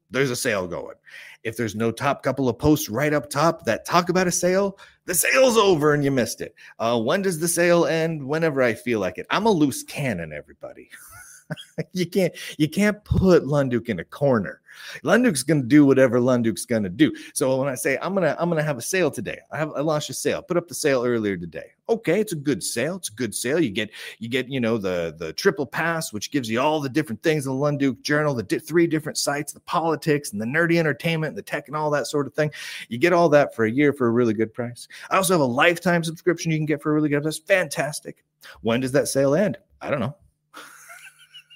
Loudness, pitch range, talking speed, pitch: -22 LUFS, 130-170 Hz, 240 wpm, 150 Hz